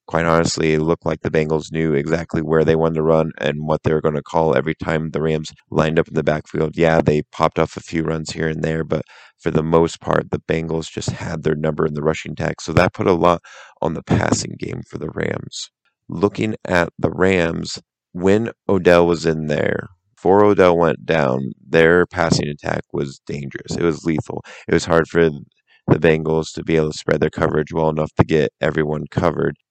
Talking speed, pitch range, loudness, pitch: 215 wpm, 80-85 Hz, -19 LUFS, 80 Hz